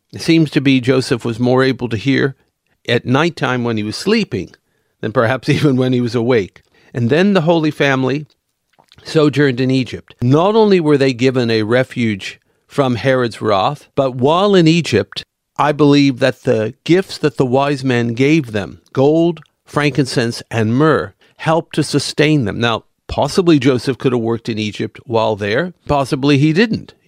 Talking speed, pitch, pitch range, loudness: 170 wpm, 135 Hz, 120-150 Hz, -15 LUFS